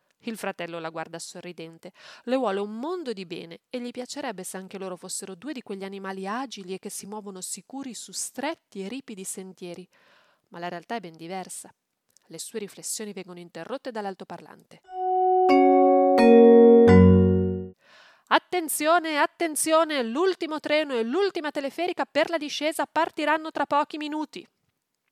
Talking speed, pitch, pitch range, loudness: 140 wpm, 225 Hz, 185-300 Hz, -23 LUFS